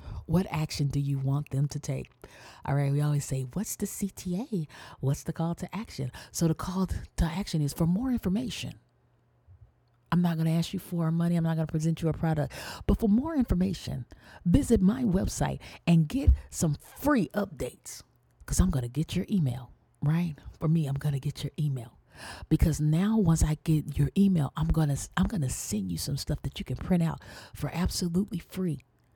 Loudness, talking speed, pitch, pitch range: -29 LUFS, 205 wpm, 160 Hz, 135-180 Hz